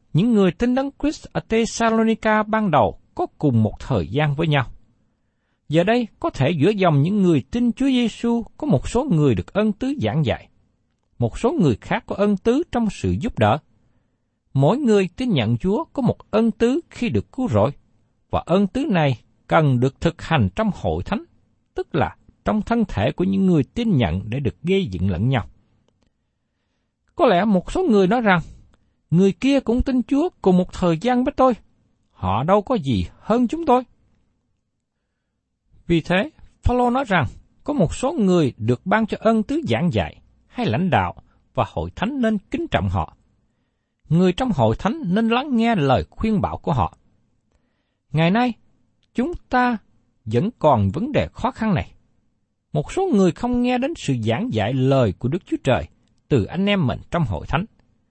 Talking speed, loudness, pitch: 190 wpm, -21 LUFS, 175 Hz